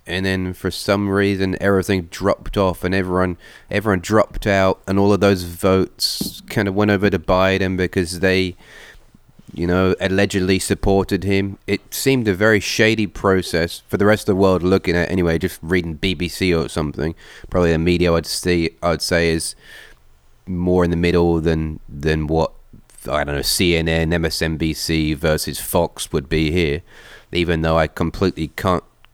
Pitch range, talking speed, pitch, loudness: 80-100 Hz, 170 wpm, 90 Hz, -19 LUFS